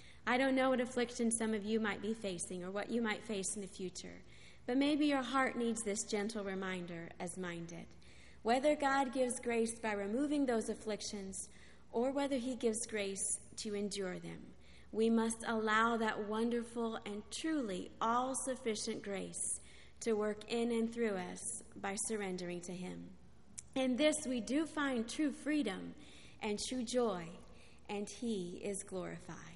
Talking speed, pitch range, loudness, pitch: 160 wpm, 195-245 Hz, -38 LUFS, 220 Hz